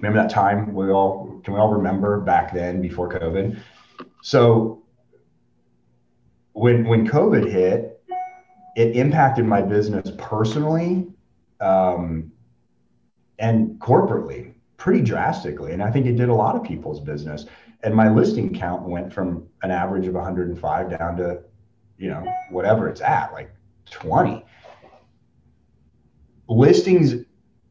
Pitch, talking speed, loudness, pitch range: 100 Hz, 125 wpm, -20 LUFS, 90-115 Hz